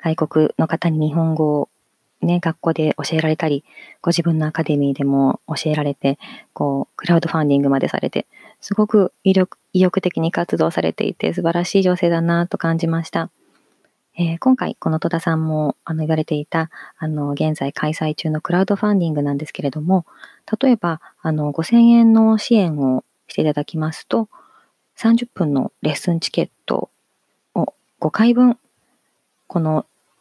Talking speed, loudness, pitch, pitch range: 310 characters per minute, -19 LUFS, 165 Hz, 155-180 Hz